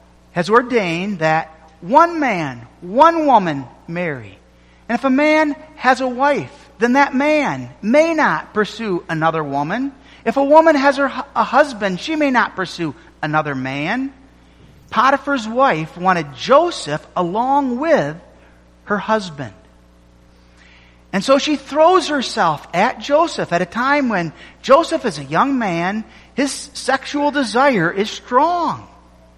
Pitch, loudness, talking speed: 220 Hz, -17 LUFS, 130 wpm